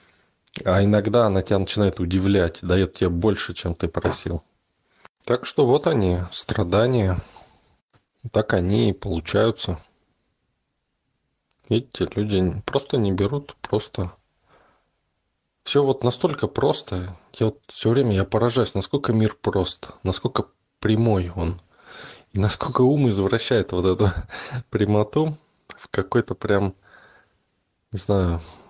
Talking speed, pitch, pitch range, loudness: 115 wpm, 100 Hz, 90-115 Hz, -23 LUFS